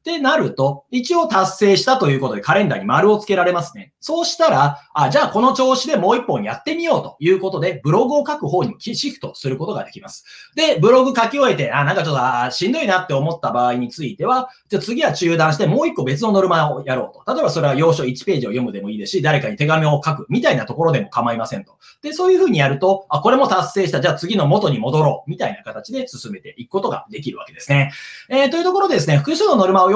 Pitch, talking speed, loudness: 190 Hz, 505 characters per minute, -17 LUFS